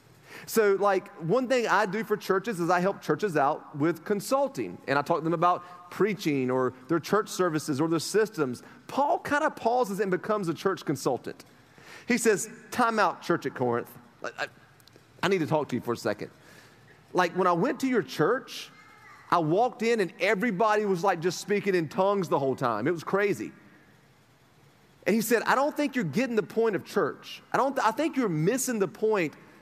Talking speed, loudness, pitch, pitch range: 205 wpm, -27 LUFS, 185 Hz, 155-215 Hz